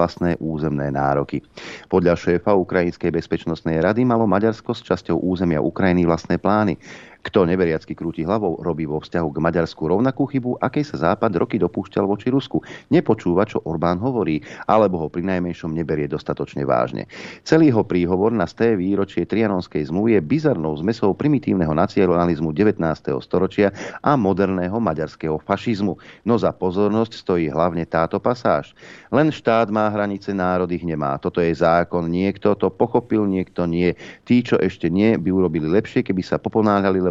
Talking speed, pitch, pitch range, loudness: 155 wpm, 90 Hz, 85-105 Hz, -20 LUFS